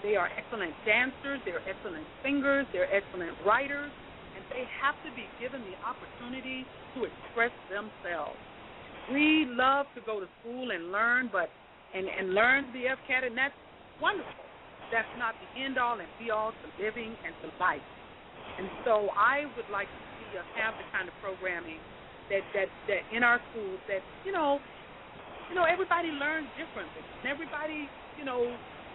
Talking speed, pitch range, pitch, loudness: 170 wpm, 220-285 Hz, 250 Hz, -31 LUFS